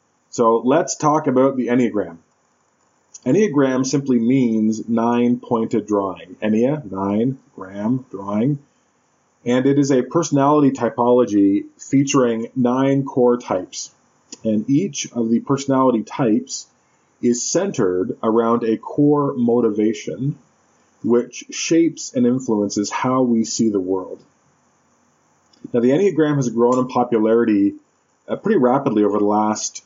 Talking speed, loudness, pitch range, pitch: 120 wpm, -18 LUFS, 110-140 Hz, 120 Hz